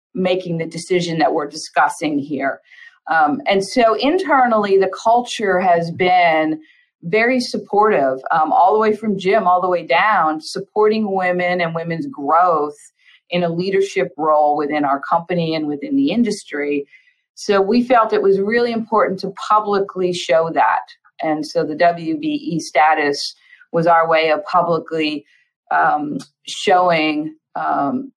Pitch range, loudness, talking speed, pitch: 160-215 Hz, -17 LUFS, 145 wpm, 180 Hz